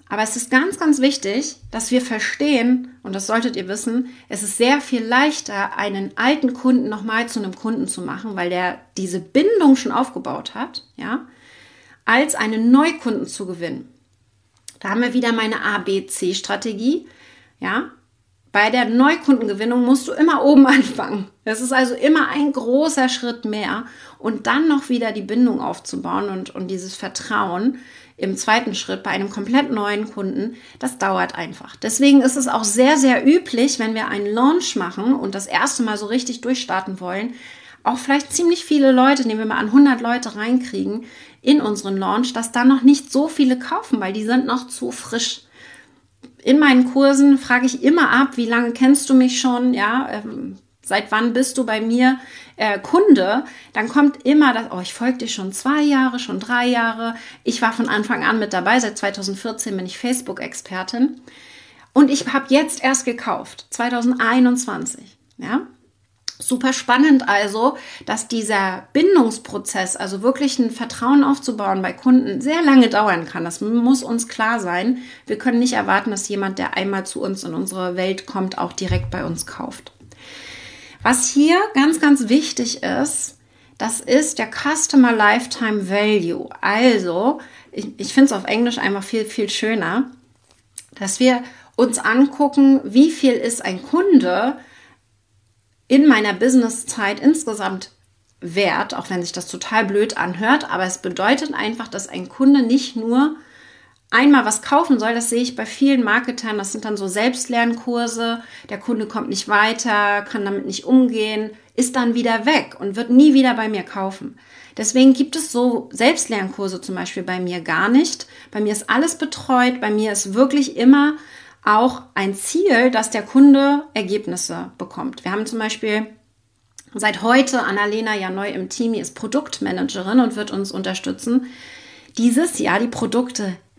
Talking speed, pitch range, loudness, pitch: 165 wpm, 210-265 Hz, -18 LUFS, 240 Hz